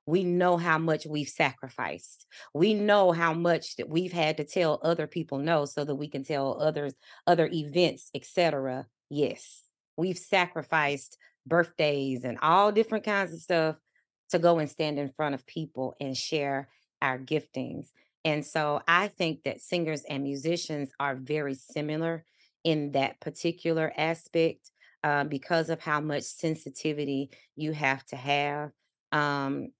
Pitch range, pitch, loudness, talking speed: 140-165 Hz, 155 Hz, -29 LUFS, 150 wpm